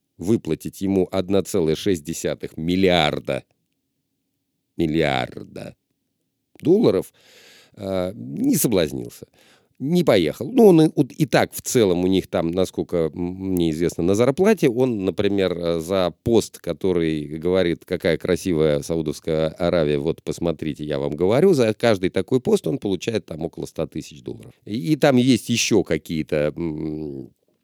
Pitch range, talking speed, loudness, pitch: 80-105 Hz, 125 wpm, -21 LUFS, 90 Hz